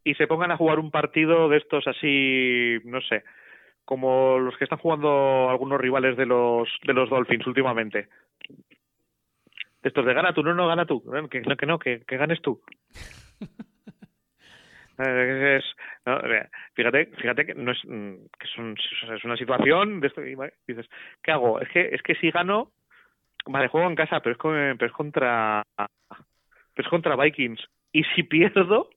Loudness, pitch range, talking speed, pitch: -23 LUFS, 125-160 Hz, 160 wpm, 135 Hz